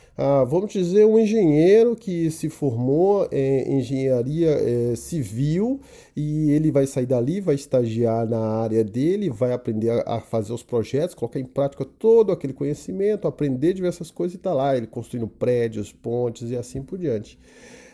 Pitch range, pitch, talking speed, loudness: 120-170 Hz, 140 Hz, 160 wpm, -22 LUFS